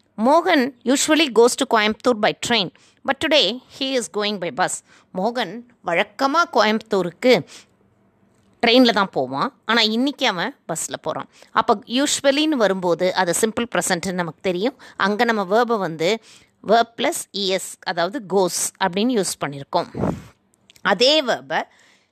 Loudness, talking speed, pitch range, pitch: -20 LUFS, 130 wpm, 190-255 Hz, 225 Hz